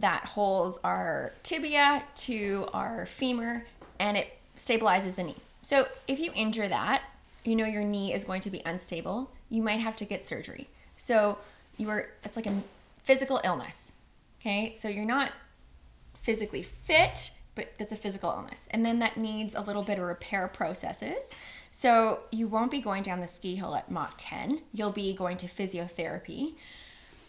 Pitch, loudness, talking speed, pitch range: 215 Hz, -30 LUFS, 170 wpm, 195-250 Hz